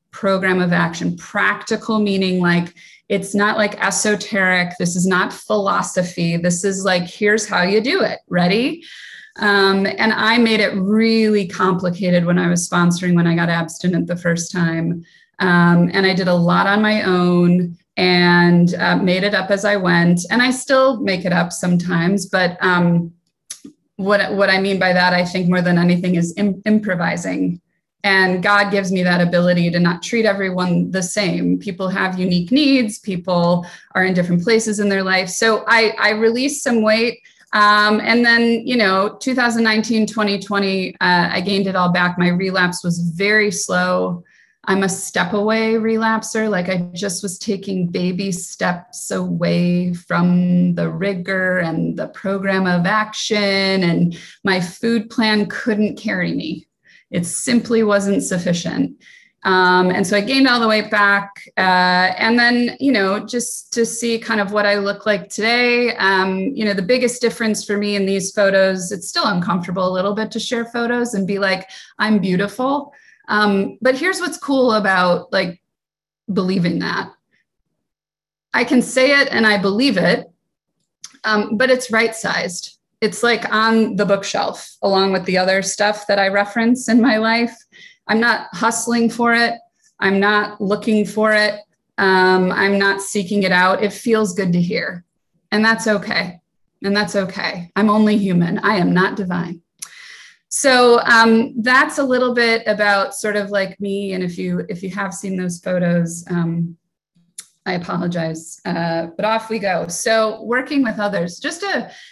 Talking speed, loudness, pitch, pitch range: 170 wpm, -17 LUFS, 195 Hz, 180-220 Hz